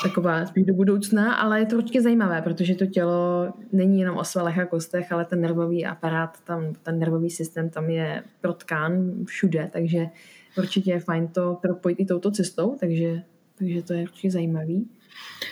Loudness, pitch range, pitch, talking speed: -24 LUFS, 170-195 Hz, 180 Hz, 175 wpm